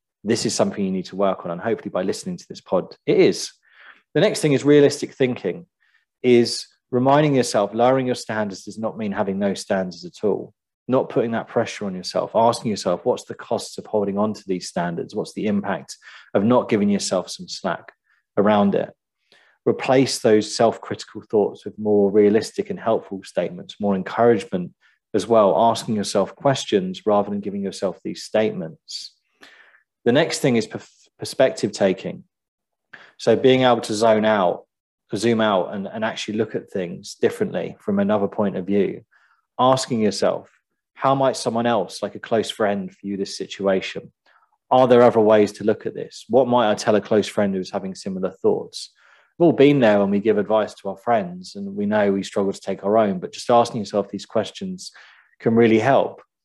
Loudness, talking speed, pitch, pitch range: -21 LUFS, 190 wpm, 110 Hz, 100-130 Hz